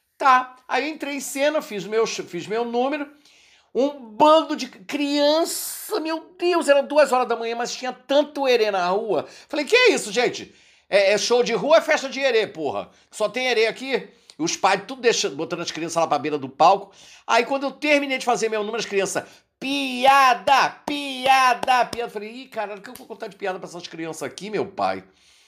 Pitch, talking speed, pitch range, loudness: 255 Hz, 205 wpm, 215-290 Hz, -21 LUFS